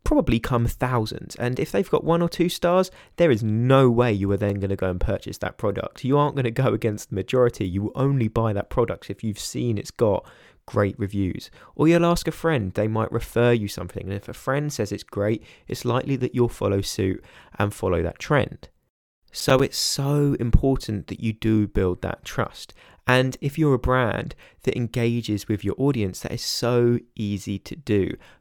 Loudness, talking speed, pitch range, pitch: -23 LUFS, 210 wpm, 100-130 Hz, 115 Hz